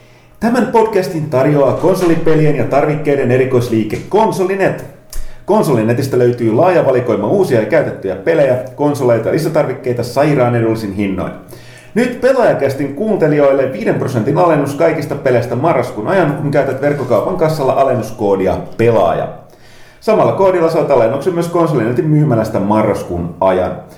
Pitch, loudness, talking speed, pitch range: 140 Hz, -13 LUFS, 115 wpm, 125-165 Hz